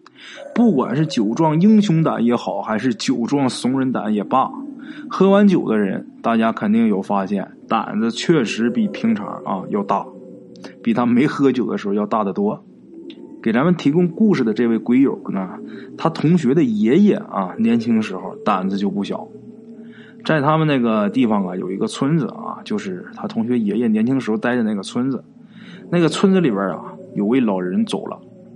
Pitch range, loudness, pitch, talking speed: 145-225 Hz, -18 LUFS, 210 Hz, 265 characters per minute